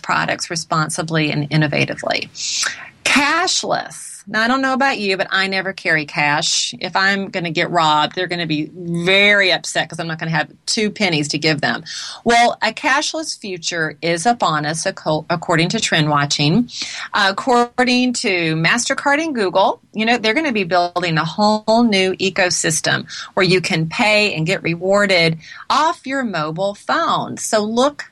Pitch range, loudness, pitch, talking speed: 165-225 Hz, -17 LUFS, 190 Hz, 165 wpm